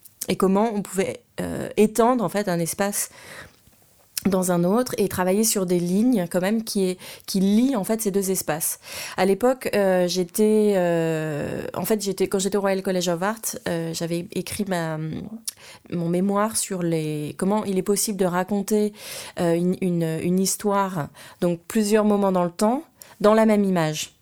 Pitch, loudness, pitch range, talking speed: 190 Hz, -23 LUFS, 175-210 Hz, 180 wpm